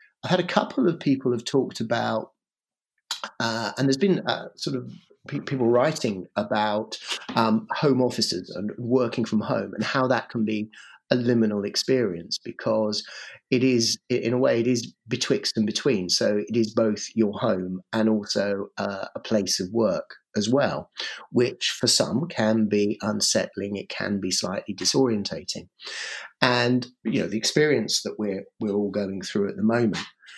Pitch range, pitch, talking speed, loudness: 105-125 Hz, 115 Hz, 170 wpm, -25 LUFS